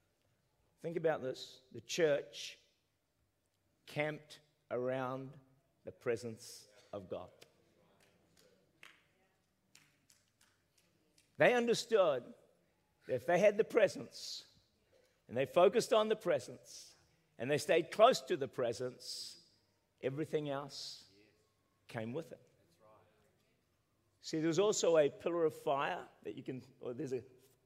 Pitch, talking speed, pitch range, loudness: 130 Hz, 110 wpm, 110-155 Hz, -36 LUFS